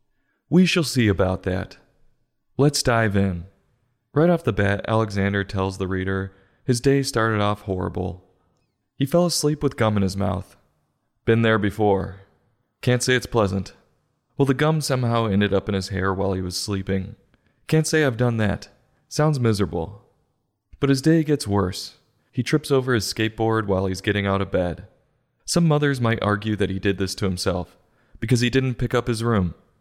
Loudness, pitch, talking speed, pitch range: -22 LUFS, 110 Hz, 180 wpm, 95-125 Hz